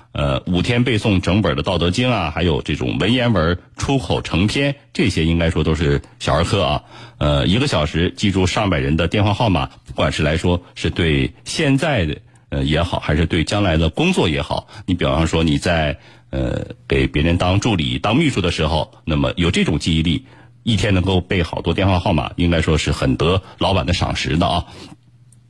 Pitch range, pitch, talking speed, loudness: 80-105 Hz, 90 Hz, 290 characters per minute, -18 LUFS